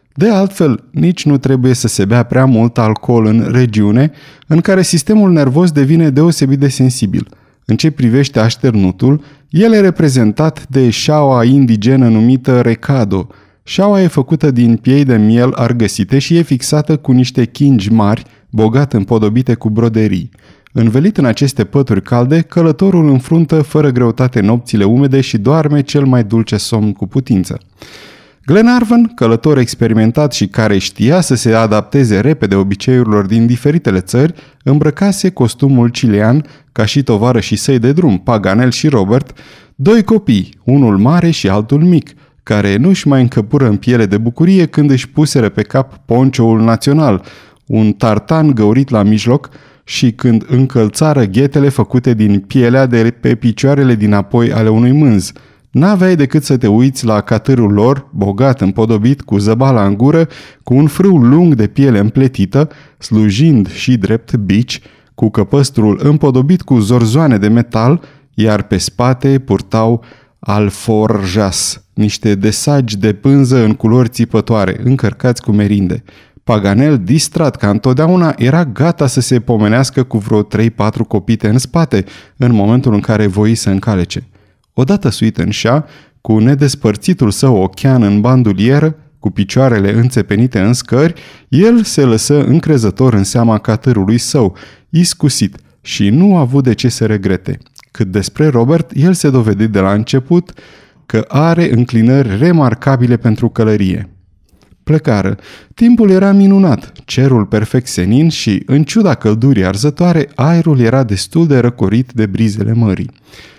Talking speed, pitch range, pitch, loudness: 145 wpm, 110-145 Hz, 125 Hz, -11 LUFS